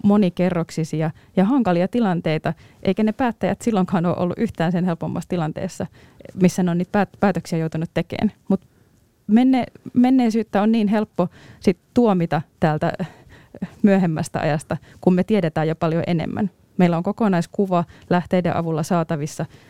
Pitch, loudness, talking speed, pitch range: 180 Hz, -21 LUFS, 130 wpm, 165-205 Hz